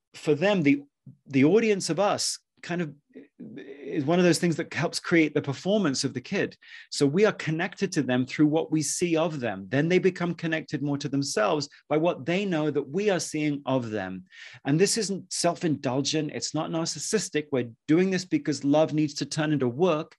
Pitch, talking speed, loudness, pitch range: 155 Hz, 200 wpm, -26 LUFS, 140-175 Hz